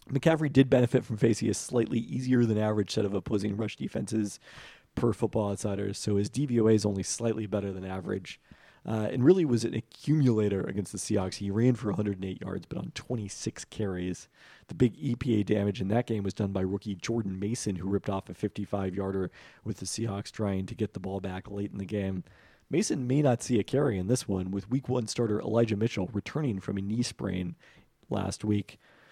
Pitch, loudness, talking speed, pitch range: 105 Hz, -30 LUFS, 200 wpm, 100-120 Hz